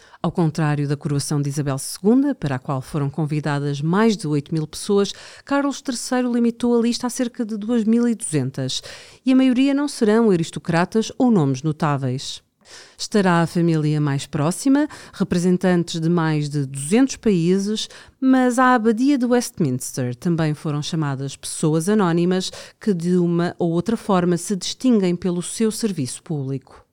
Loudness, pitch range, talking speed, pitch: -20 LUFS, 150-230 Hz, 150 wpm, 175 Hz